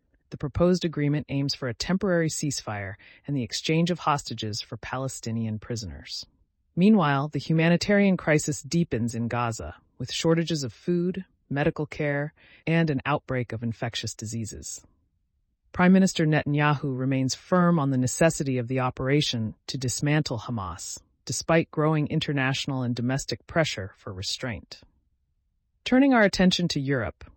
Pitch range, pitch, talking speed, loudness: 110-160 Hz, 135 Hz, 135 wpm, -26 LUFS